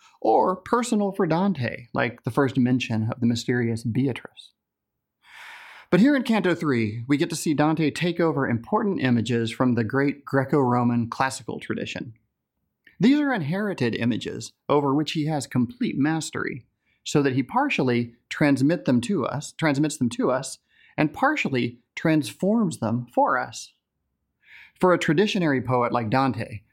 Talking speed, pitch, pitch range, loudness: 150 wpm, 140 Hz, 120-175 Hz, -24 LUFS